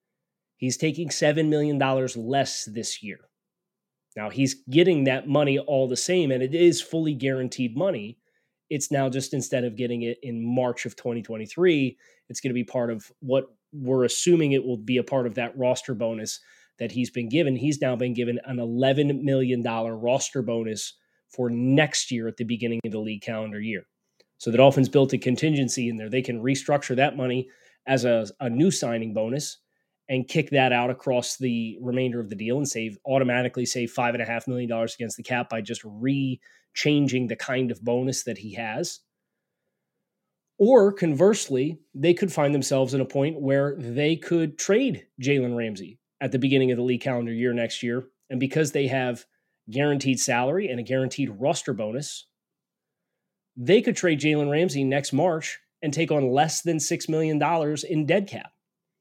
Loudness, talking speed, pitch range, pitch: -25 LUFS, 180 wpm, 120-145 Hz, 130 Hz